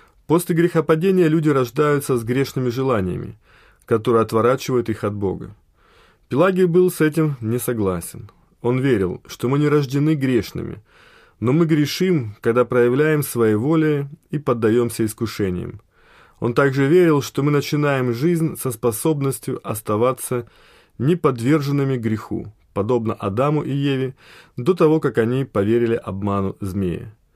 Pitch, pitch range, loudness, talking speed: 130 Hz, 115-155 Hz, -20 LUFS, 125 wpm